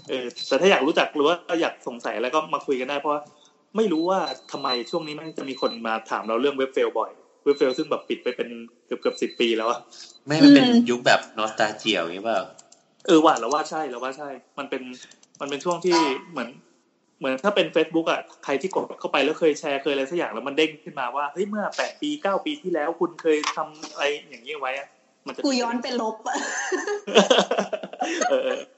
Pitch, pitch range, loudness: 155 Hz, 140-220 Hz, -23 LUFS